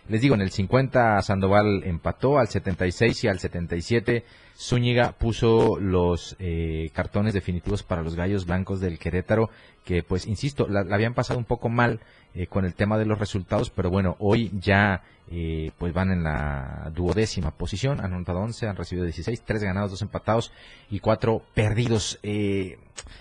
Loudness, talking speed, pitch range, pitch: -25 LUFS, 170 wpm, 90-115 Hz, 100 Hz